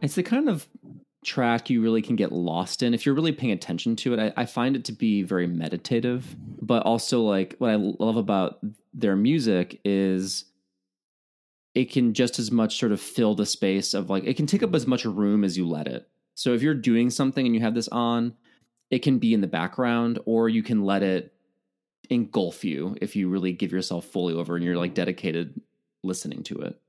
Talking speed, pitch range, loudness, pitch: 215 wpm, 95-120 Hz, -25 LUFS, 110 Hz